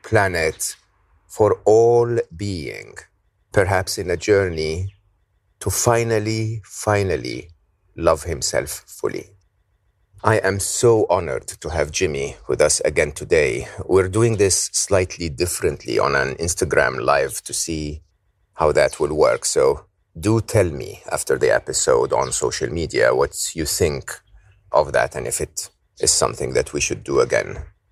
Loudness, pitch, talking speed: -20 LUFS, 100 Hz, 140 wpm